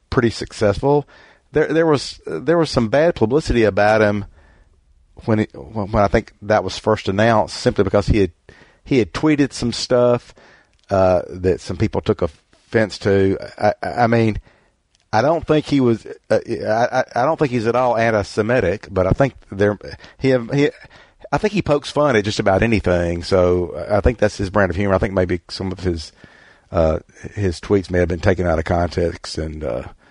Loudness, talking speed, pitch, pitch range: -18 LUFS, 190 wpm, 105 Hz, 90-125 Hz